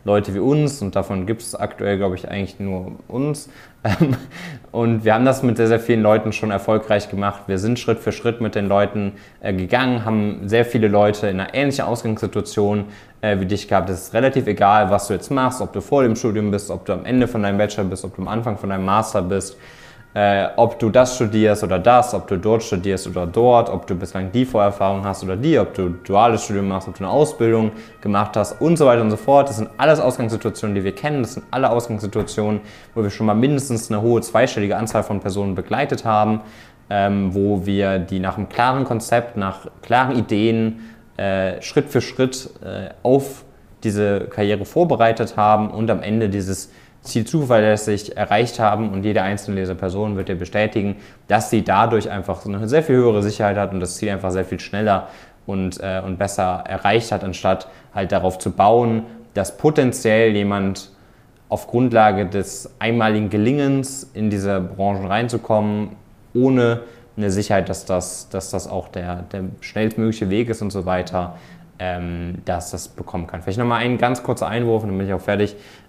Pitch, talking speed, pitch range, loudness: 105 Hz, 190 wpm, 100-115 Hz, -19 LUFS